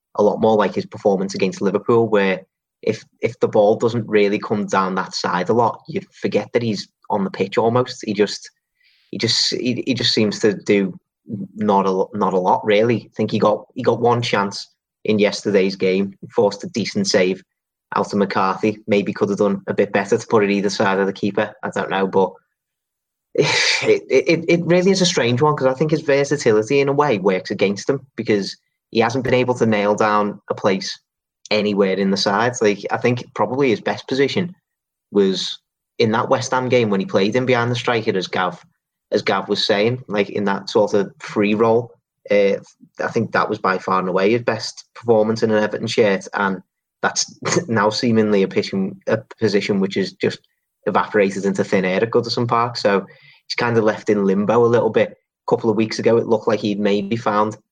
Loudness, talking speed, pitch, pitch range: -19 LUFS, 215 wpm, 110 Hz, 100-125 Hz